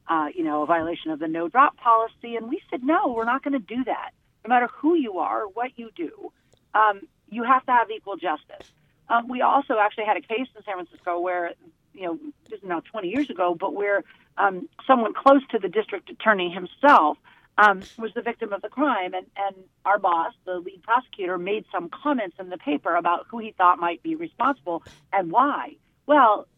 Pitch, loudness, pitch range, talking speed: 215 Hz, -23 LUFS, 180-255 Hz, 210 wpm